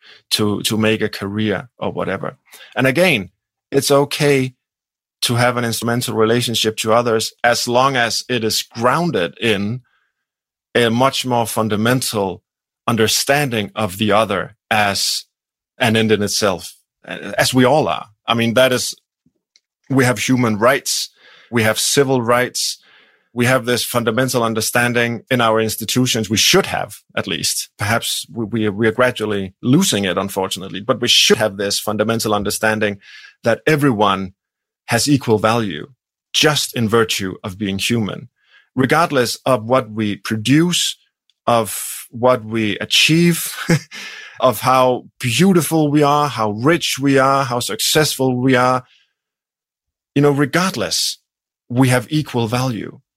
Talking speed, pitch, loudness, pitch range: 140 wpm, 120 Hz, -17 LUFS, 110-130 Hz